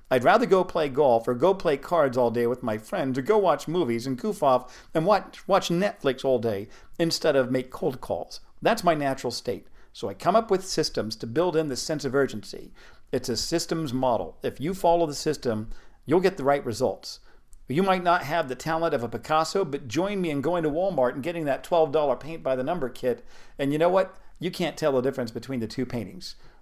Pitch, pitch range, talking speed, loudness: 150 Hz, 125-175 Hz, 230 wpm, -26 LUFS